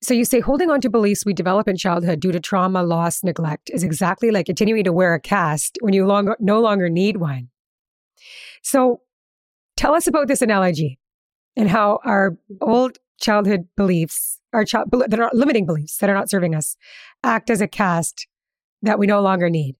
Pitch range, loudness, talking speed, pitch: 175-225 Hz, -19 LUFS, 190 wpm, 200 Hz